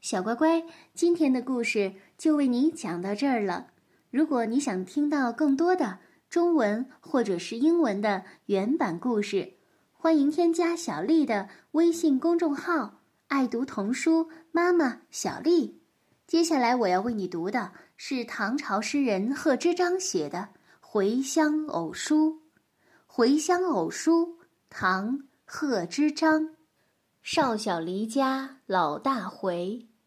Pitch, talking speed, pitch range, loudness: 280 Hz, 190 characters per minute, 225-320 Hz, -27 LUFS